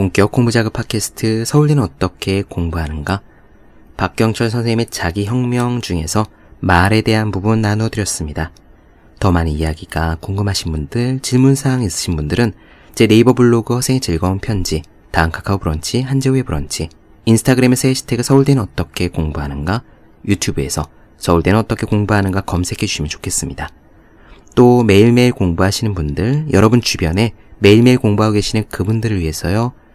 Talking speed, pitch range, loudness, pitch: 380 characters per minute, 85-120 Hz, -15 LUFS, 105 Hz